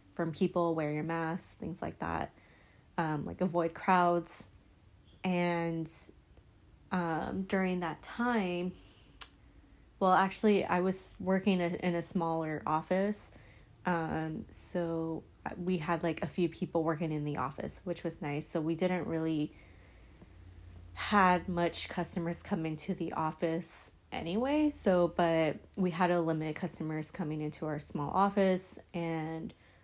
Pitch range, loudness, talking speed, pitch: 155-180 Hz, -33 LUFS, 135 wpm, 165 Hz